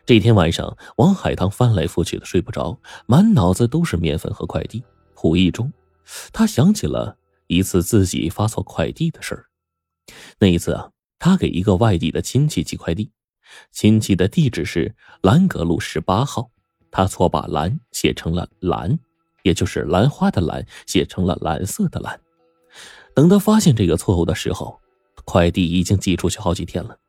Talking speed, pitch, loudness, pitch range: 255 characters per minute, 95 Hz, -19 LUFS, 85-120 Hz